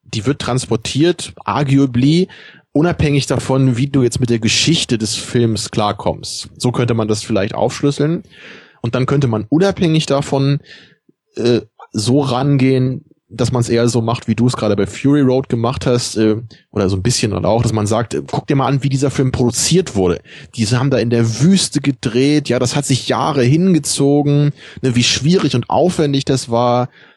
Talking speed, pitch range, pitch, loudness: 190 wpm, 115-145 Hz, 125 Hz, -15 LUFS